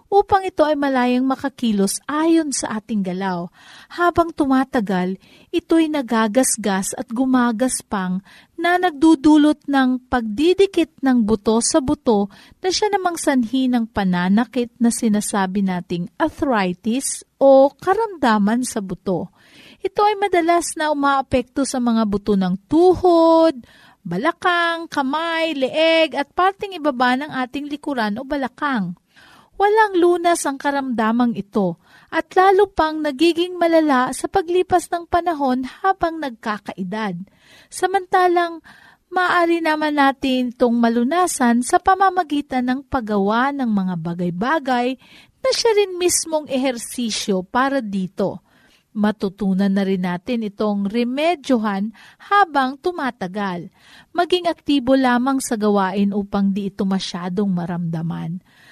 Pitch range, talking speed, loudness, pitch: 215-330 Hz, 115 wpm, -19 LUFS, 260 Hz